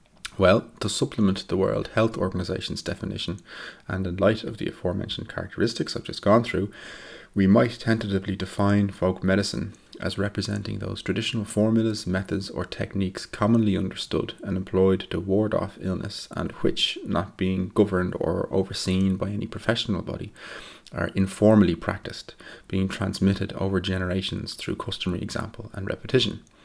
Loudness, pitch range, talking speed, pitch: -25 LUFS, 95-105 Hz, 145 wpm, 100 Hz